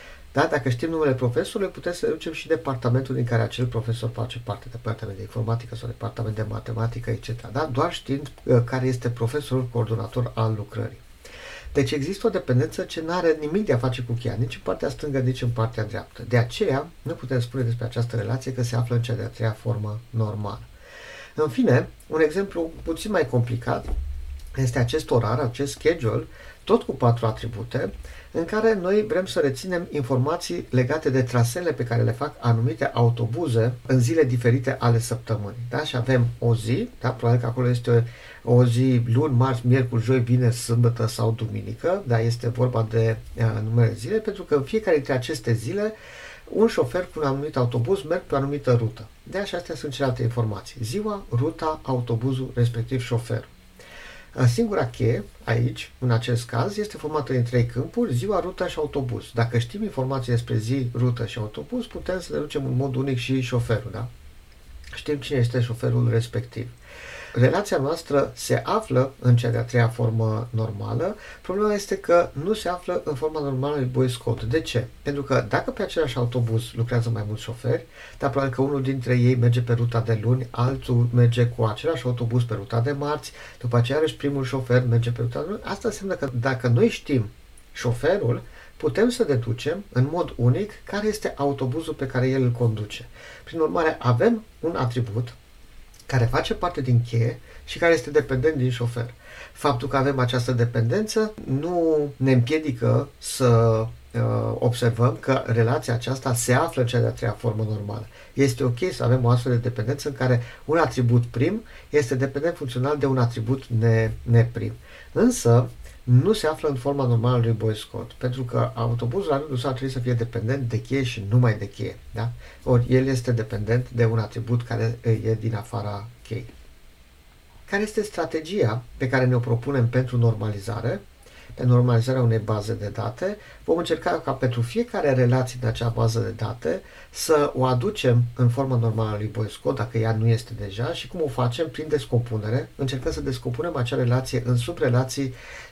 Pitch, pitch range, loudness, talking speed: 125 Hz, 115-140 Hz, -24 LUFS, 180 wpm